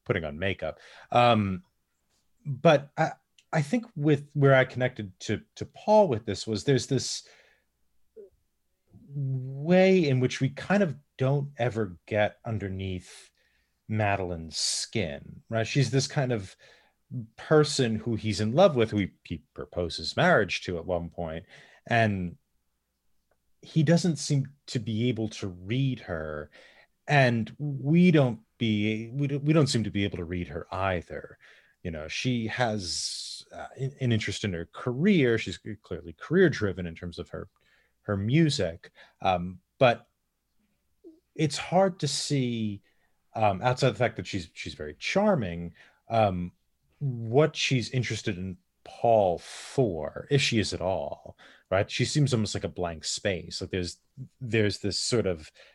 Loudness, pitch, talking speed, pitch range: -27 LUFS, 115 Hz, 150 wpm, 95-140 Hz